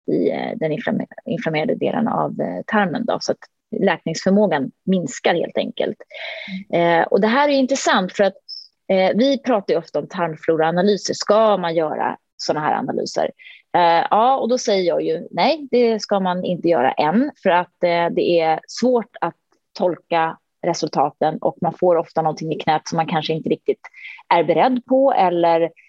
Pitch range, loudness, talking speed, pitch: 165-245 Hz, -19 LUFS, 170 wpm, 185 Hz